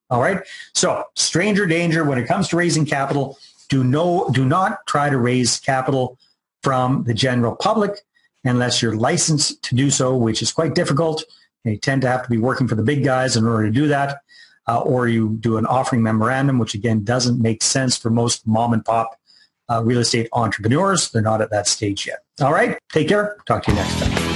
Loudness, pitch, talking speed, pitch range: -19 LUFS, 125 Hz, 210 wpm, 115-145 Hz